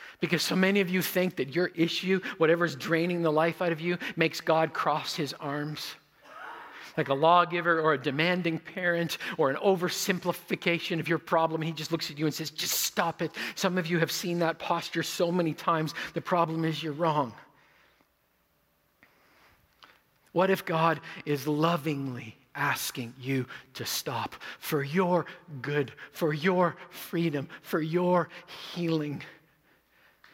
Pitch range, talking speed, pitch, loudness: 155-175 Hz, 155 wpm, 165 Hz, -29 LUFS